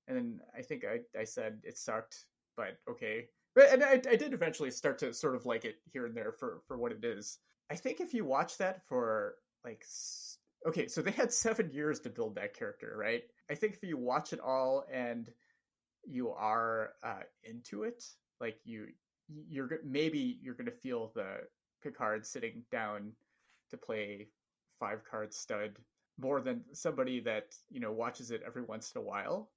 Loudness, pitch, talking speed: -36 LUFS, 215 Hz, 185 wpm